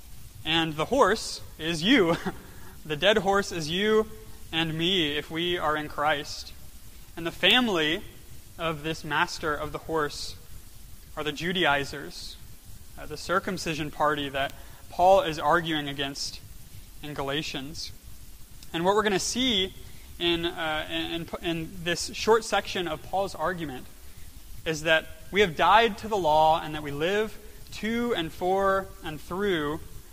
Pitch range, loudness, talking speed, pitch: 145-185 Hz, -26 LUFS, 145 wpm, 160 Hz